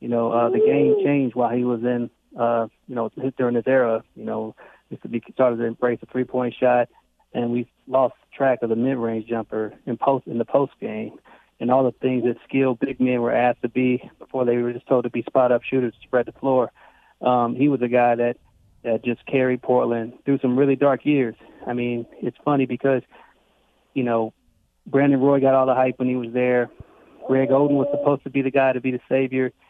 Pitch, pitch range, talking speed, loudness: 125 Hz, 120-130 Hz, 225 wpm, -22 LUFS